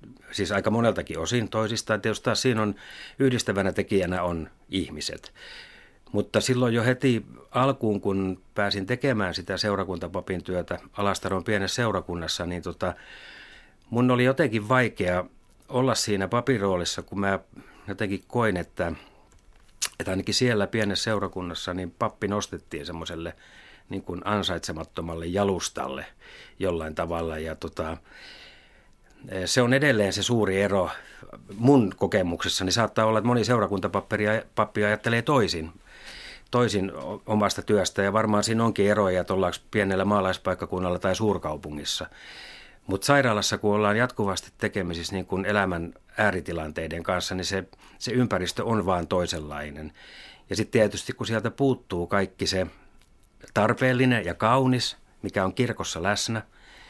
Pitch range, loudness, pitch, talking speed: 90-110 Hz, -26 LUFS, 100 Hz, 125 wpm